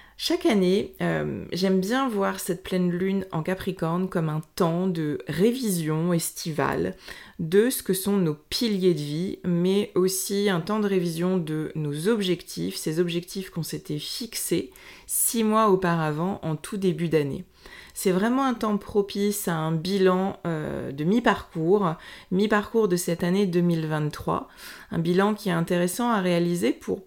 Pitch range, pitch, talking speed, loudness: 170-205 Hz, 185 Hz, 155 wpm, -25 LUFS